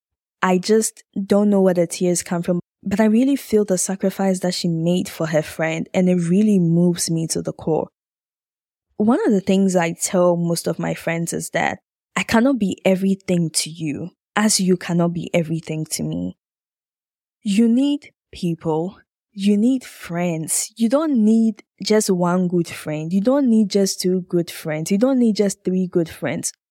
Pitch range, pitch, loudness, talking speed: 170-210 Hz, 185 Hz, -20 LUFS, 180 wpm